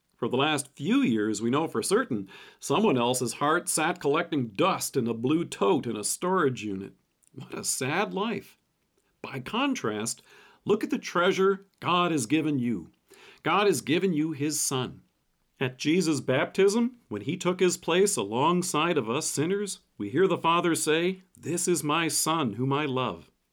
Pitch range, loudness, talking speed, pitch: 130-180 Hz, -27 LUFS, 170 wpm, 155 Hz